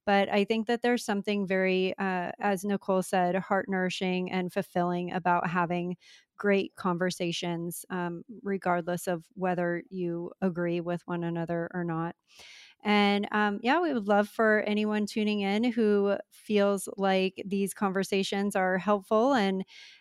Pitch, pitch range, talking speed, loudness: 195 Hz, 180-205 Hz, 145 wpm, -29 LUFS